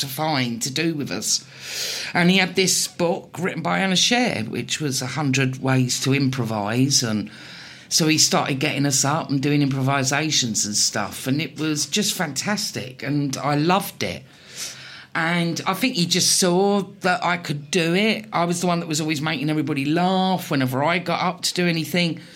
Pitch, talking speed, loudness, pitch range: 155 Hz, 190 wpm, -21 LUFS, 140-180 Hz